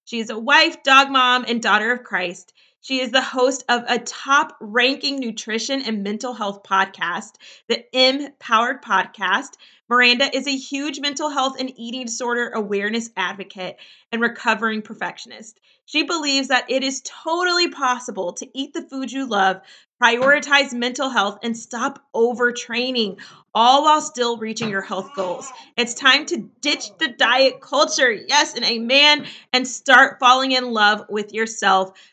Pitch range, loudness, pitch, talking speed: 220-270 Hz, -19 LUFS, 245 Hz, 155 wpm